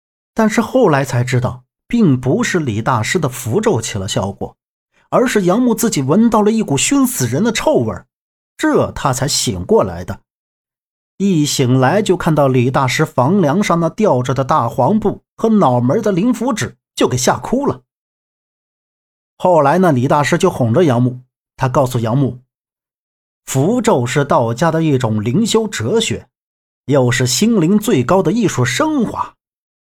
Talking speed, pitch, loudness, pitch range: 230 characters per minute, 150 Hz, -15 LUFS, 125-210 Hz